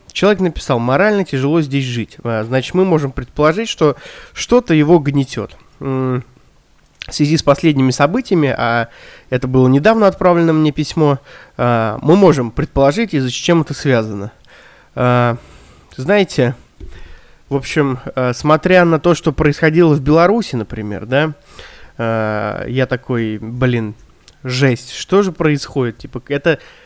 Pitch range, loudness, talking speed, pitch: 125-165 Hz, -15 LUFS, 120 wpm, 140 Hz